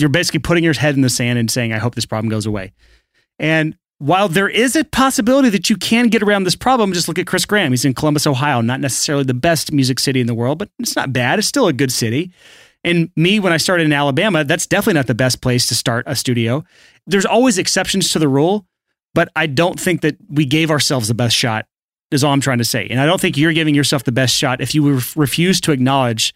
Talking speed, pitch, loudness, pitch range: 255 wpm, 150 Hz, -15 LUFS, 130-180 Hz